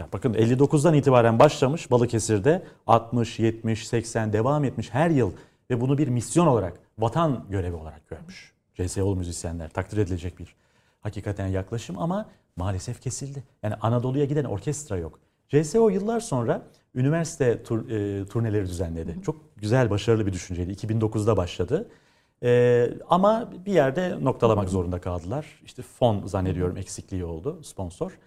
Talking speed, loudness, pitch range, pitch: 135 wpm, -25 LUFS, 100-140 Hz, 115 Hz